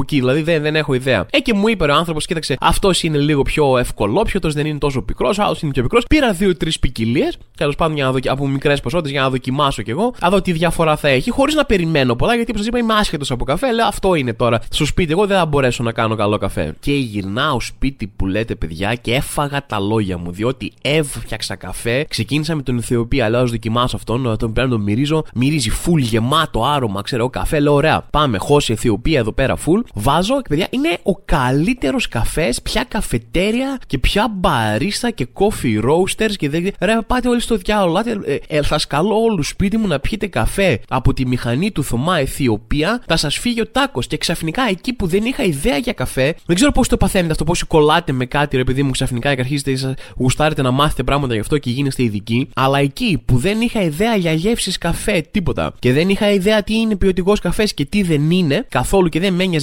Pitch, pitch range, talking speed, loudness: 150 Hz, 125-190 Hz, 220 wpm, -17 LUFS